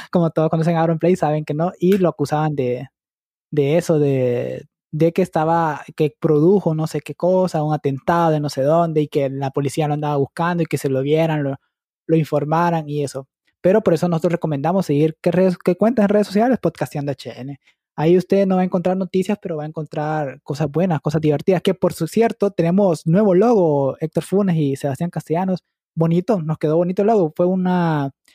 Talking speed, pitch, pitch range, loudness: 205 wpm, 165 Hz, 150-180 Hz, -19 LUFS